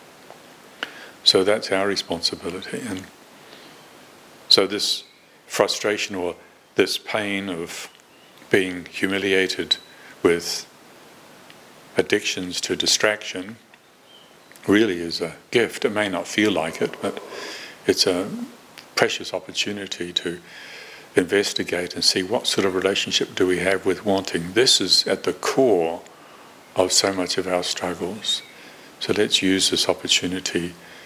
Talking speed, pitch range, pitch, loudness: 120 wpm, 90-100 Hz, 95 Hz, -21 LUFS